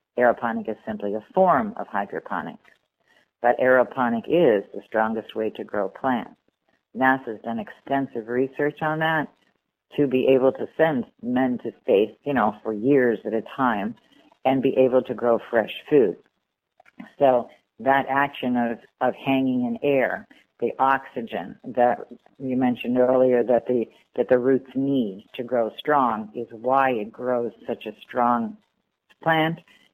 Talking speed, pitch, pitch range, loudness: 150 wpm, 125 Hz, 120-135 Hz, -23 LUFS